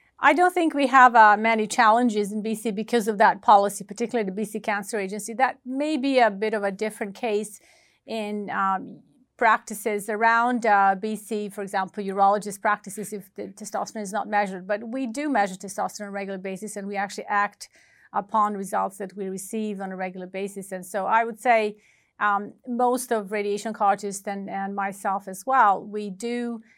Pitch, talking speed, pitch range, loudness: 210 Hz, 185 wpm, 200-230 Hz, -24 LUFS